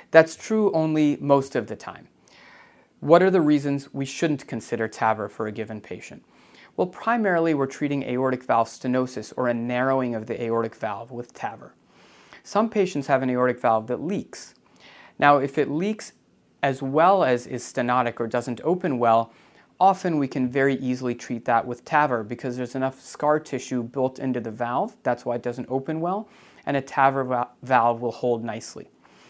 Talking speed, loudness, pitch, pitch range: 180 wpm, -24 LUFS, 130 Hz, 120-145 Hz